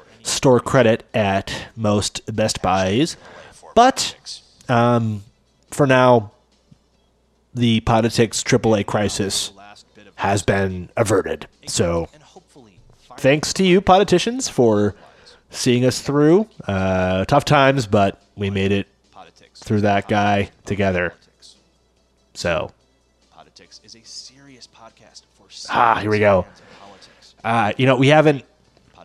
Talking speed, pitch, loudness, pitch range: 110 wpm, 110 Hz, -18 LUFS, 100-130 Hz